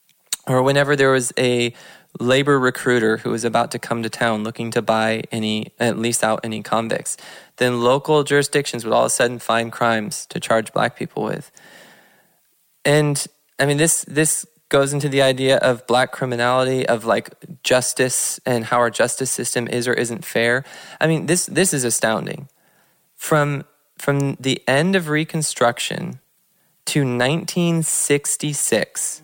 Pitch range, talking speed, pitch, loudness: 120-150 Hz, 155 wpm, 130 Hz, -19 LUFS